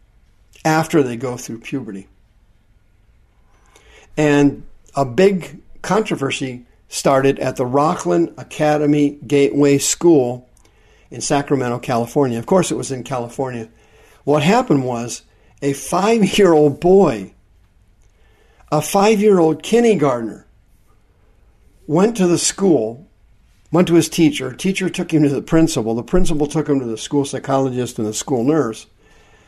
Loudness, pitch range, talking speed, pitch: -17 LUFS, 110-160 Hz, 120 wpm, 140 Hz